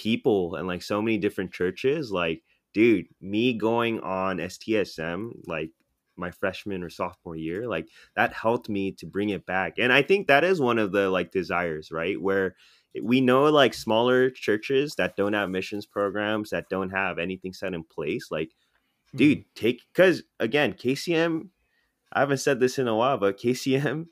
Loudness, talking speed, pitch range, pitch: -25 LUFS, 175 wpm, 95-125 Hz, 105 Hz